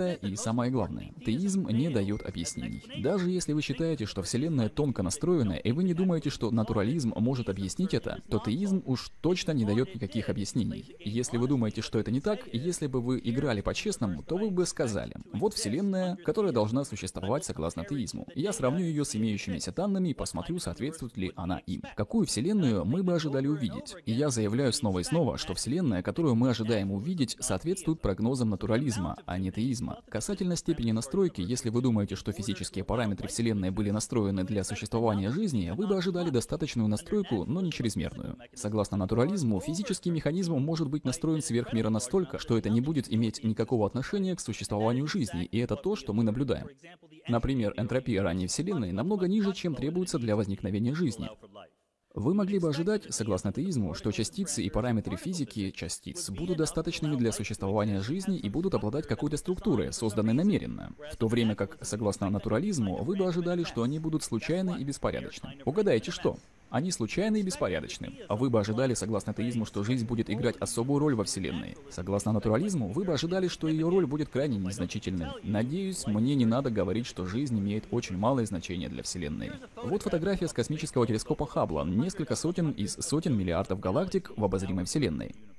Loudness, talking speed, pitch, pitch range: -30 LUFS, 175 wpm, 120 Hz, 105-160 Hz